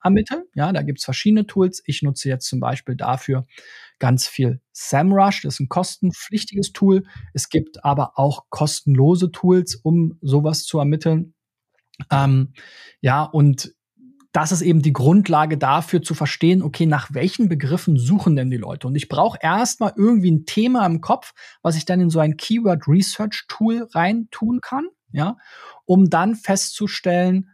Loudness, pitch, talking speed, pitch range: -19 LUFS, 165 Hz, 160 wpm, 145-195 Hz